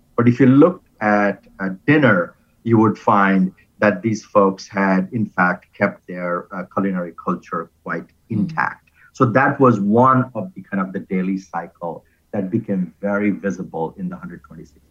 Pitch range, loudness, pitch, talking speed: 95-115 Hz, -19 LUFS, 100 Hz, 165 wpm